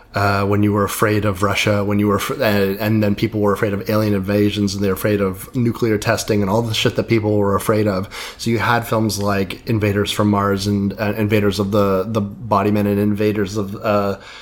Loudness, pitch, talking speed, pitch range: -18 LUFS, 105 Hz, 235 wpm, 100-110 Hz